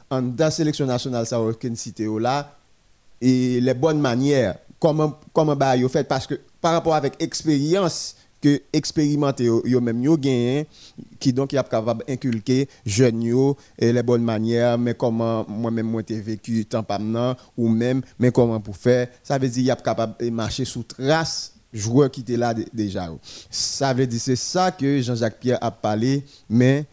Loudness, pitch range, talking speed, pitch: -22 LUFS, 115-140 Hz, 170 wpm, 125 Hz